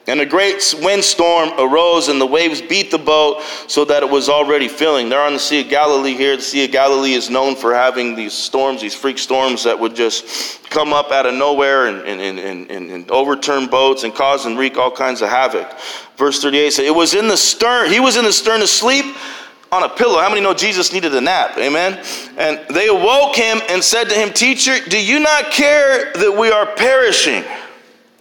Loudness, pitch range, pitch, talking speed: -13 LUFS, 135-210 Hz, 150 Hz, 215 wpm